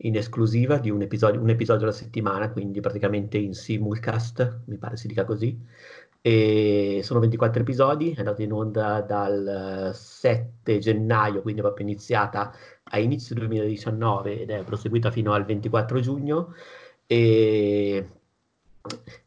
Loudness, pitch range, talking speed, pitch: -24 LUFS, 105-115 Hz, 135 wpm, 110 Hz